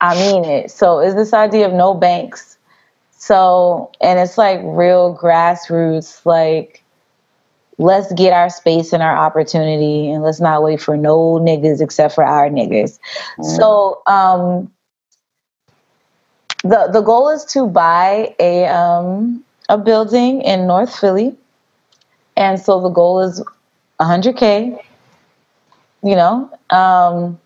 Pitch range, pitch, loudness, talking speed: 165-205 Hz, 180 Hz, -13 LUFS, 135 wpm